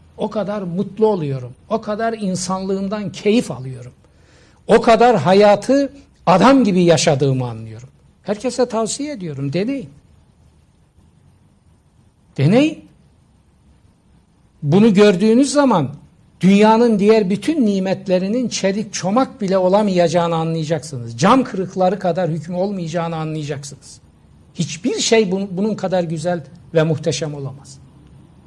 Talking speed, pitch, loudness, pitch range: 100 wpm, 190 Hz, -17 LUFS, 160-215 Hz